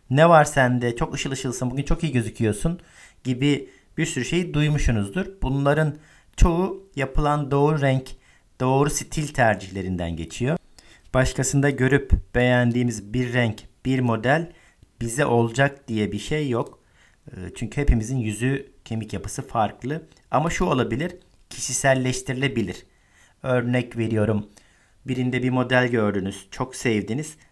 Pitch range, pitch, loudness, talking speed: 115-145 Hz, 130 Hz, -23 LUFS, 120 wpm